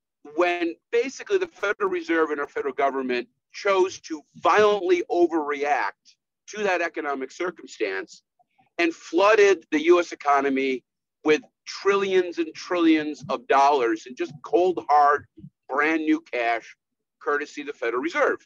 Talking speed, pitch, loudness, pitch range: 130 wpm, 165 Hz, -23 LUFS, 145-200 Hz